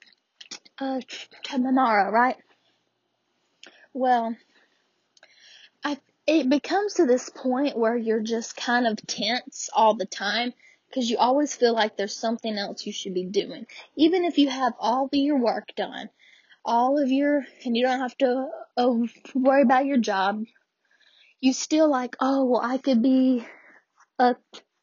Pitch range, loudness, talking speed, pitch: 230-280 Hz, -24 LUFS, 150 wpm, 255 Hz